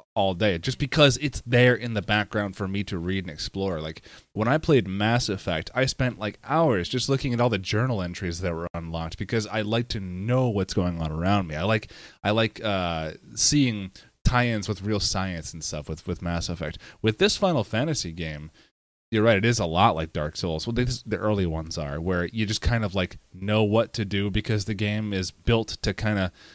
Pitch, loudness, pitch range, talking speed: 105 Hz, -25 LUFS, 90-115 Hz, 225 wpm